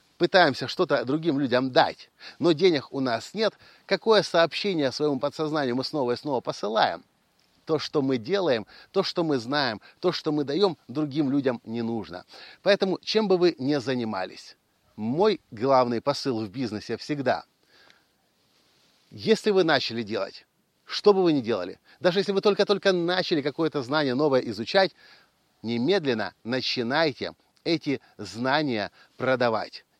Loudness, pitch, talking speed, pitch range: -25 LUFS, 150 Hz, 140 wpm, 125-180 Hz